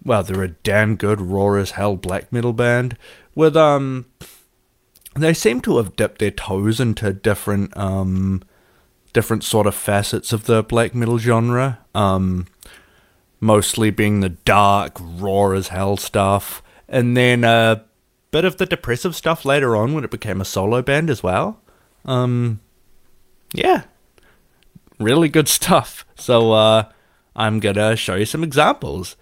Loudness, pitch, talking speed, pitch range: -18 LUFS, 110 Hz, 150 wpm, 100-125 Hz